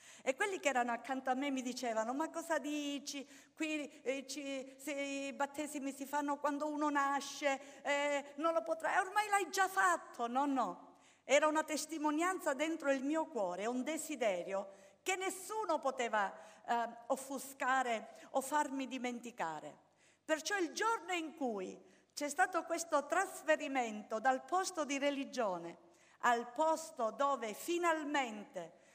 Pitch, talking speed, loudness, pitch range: 285 Hz, 140 wpm, -37 LUFS, 260-315 Hz